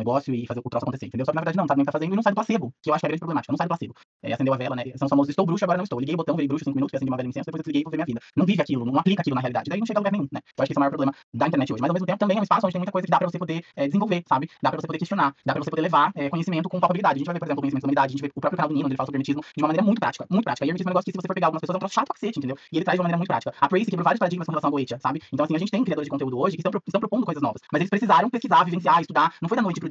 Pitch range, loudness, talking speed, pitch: 140-185 Hz, -24 LUFS, 355 wpm, 160 Hz